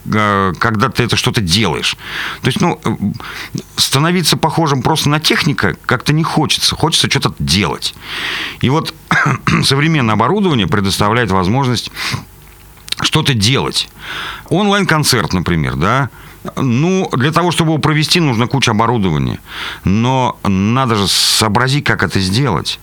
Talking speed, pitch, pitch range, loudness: 120 wpm, 135 Hz, 110-160 Hz, -13 LUFS